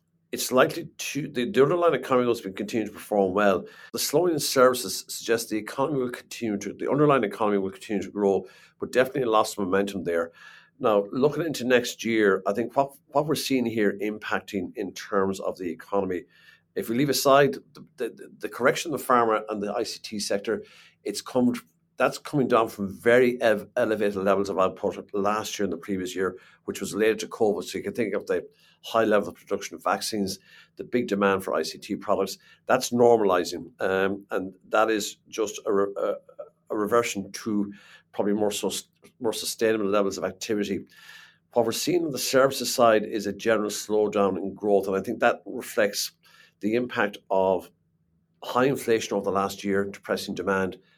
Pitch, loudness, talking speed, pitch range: 105 Hz, -26 LUFS, 185 wpm, 100-125 Hz